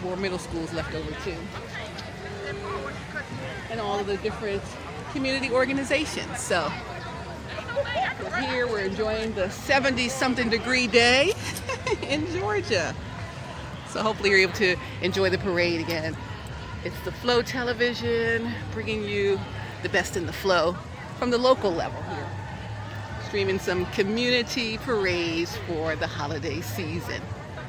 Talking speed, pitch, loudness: 125 wpm, 180 Hz, -26 LUFS